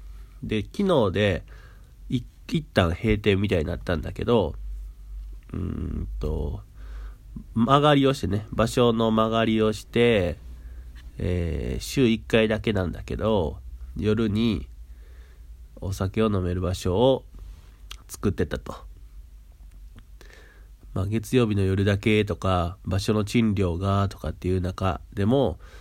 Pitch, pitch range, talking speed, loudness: 95 Hz, 75-110 Hz, 215 characters per minute, -25 LUFS